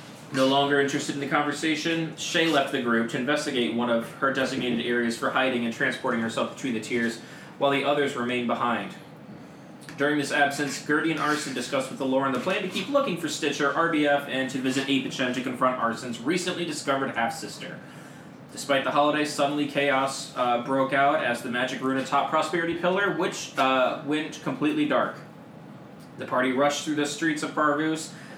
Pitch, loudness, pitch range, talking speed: 140 Hz, -25 LUFS, 130-150 Hz, 185 wpm